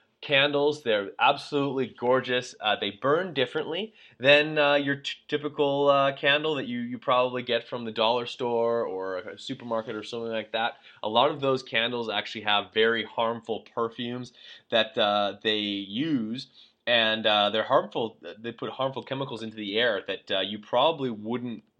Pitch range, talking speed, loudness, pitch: 110-140 Hz, 170 wpm, -26 LUFS, 120 Hz